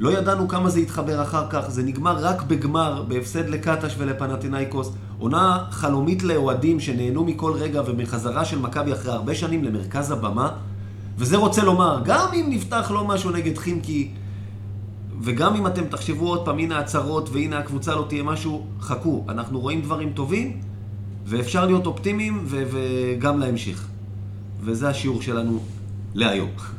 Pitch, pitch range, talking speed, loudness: 135 Hz, 105-160 Hz, 150 wpm, -23 LUFS